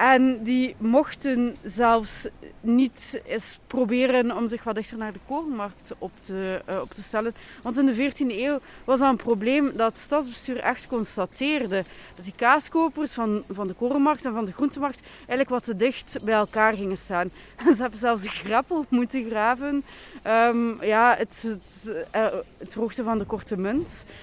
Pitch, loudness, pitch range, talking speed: 235 Hz, -25 LUFS, 215-265 Hz, 170 wpm